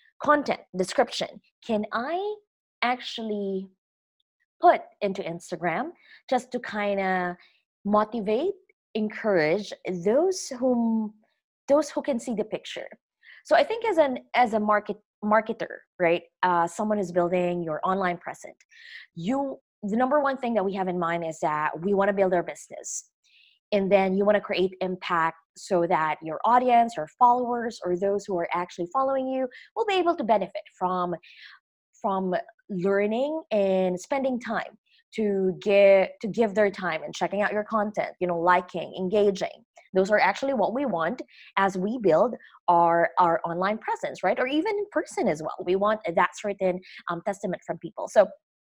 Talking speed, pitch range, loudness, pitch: 160 wpm, 180-255 Hz, -26 LUFS, 205 Hz